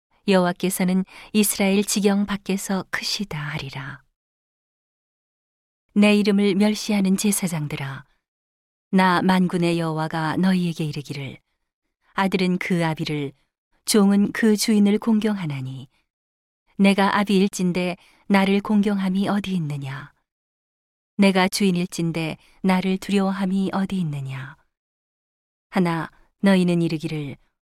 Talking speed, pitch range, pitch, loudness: 245 characters per minute, 155-200 Hz, 185 Hz, -21 LUFS